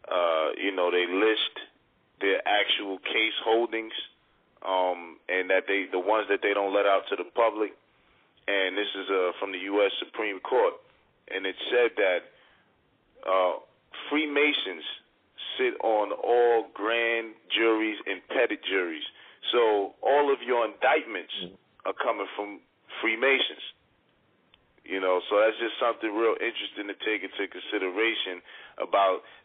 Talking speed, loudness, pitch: 140 wpm, -27 LUFS, 115 Hz